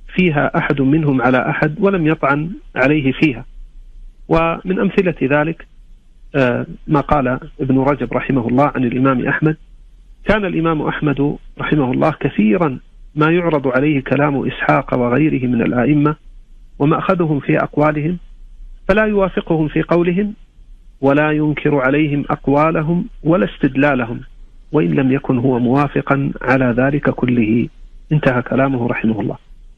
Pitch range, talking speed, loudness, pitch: 130-160 Hz, 120 wpm, -16 LUFS, 145 Hz